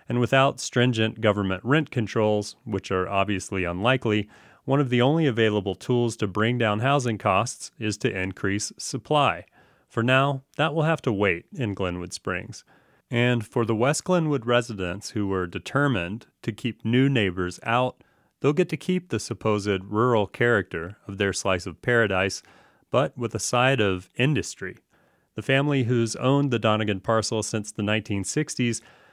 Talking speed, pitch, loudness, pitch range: 160 wpm, 115 Hz, -24 LUFS, 100-130 Hz